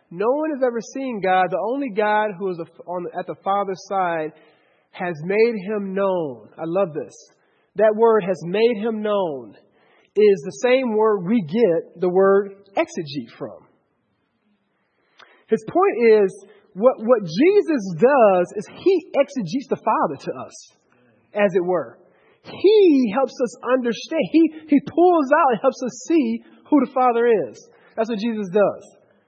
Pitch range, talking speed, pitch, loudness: 195-265 Hz, 160 wpm, 220 Hz, -20 LUFS